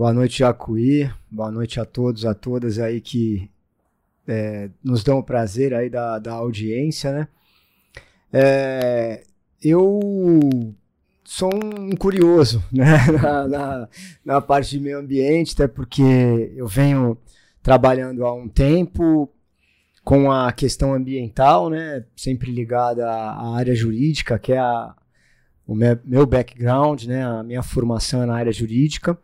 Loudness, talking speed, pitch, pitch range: -19 LUFS, 140 wpm, 125 Hz, 115-140 Hz